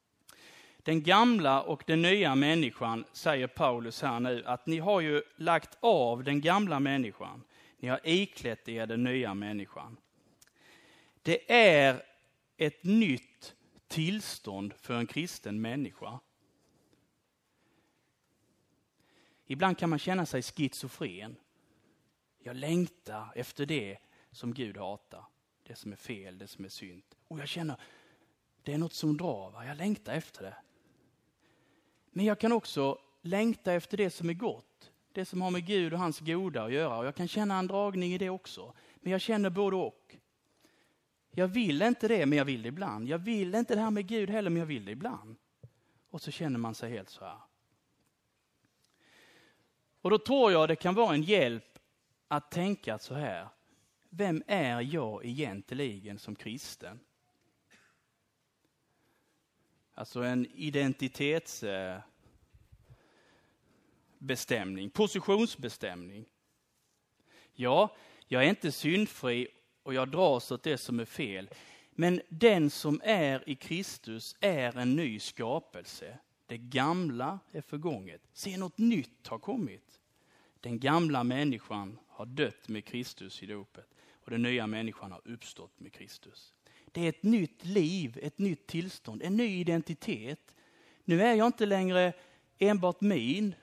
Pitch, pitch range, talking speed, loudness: 150 Hz, 120-180 Hz, 145 wpm, -31 LUFS